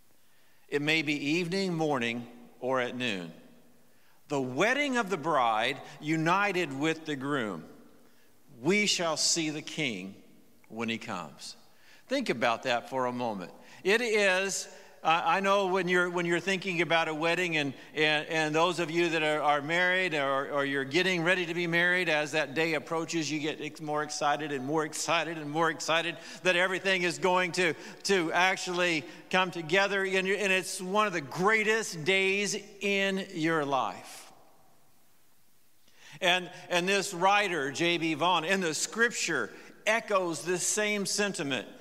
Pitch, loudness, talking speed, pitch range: 170 Hz, -28 LUFS, 155 wpm, 155-190 Hz